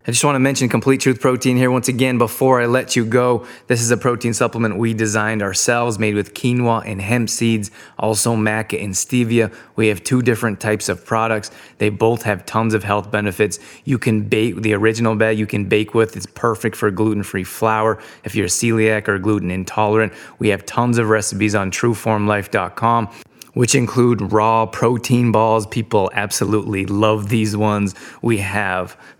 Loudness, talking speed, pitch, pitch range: -18 LUFS, 180 wpm, 110 Hz, 105-120 Hz